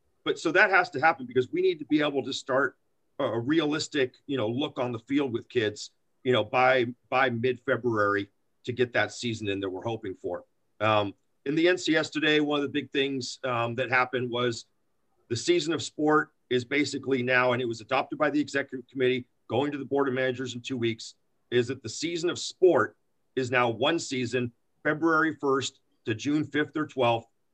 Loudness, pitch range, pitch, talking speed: -27 LUFS, 120-150 Hz, 130 Hz, 205 wpm